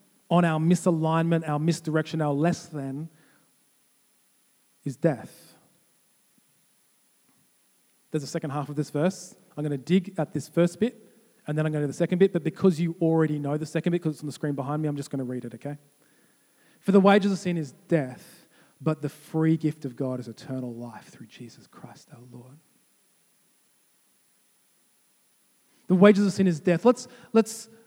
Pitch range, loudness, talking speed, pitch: 145-180 Hz, -26 LUFS, 175 wpm, 160 Hz